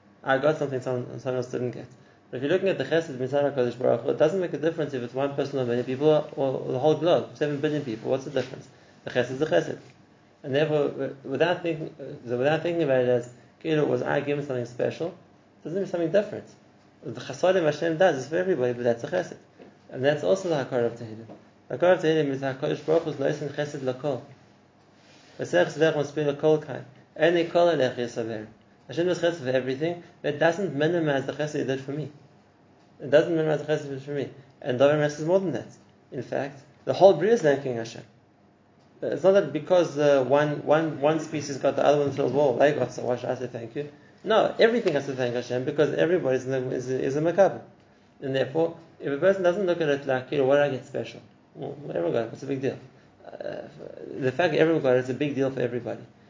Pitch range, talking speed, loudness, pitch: 130-160 Hz, 220 wpm, -25 LUFS, 145 Hz